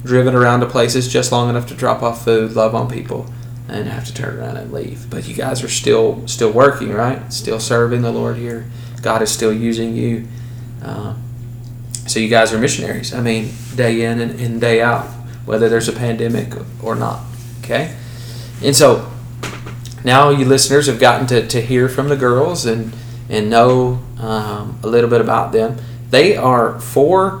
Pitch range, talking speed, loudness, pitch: 115-125 Hz, 185 wpm, -15 LUFS, 120 Hz